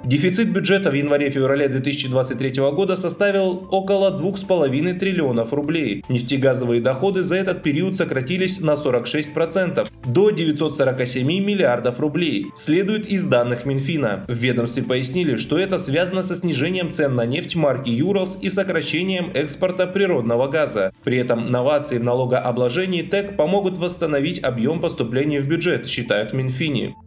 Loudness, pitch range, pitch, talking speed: -20 LUFS, 130-185 Hz, 150 Hz, 135 wpm